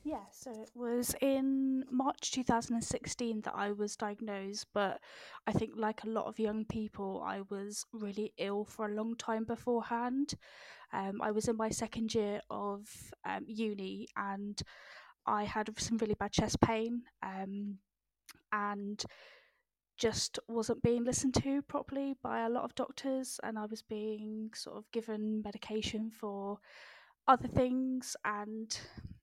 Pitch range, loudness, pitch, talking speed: 210-240 Hz, -37 LUFS, 220 Hz, 155 wpm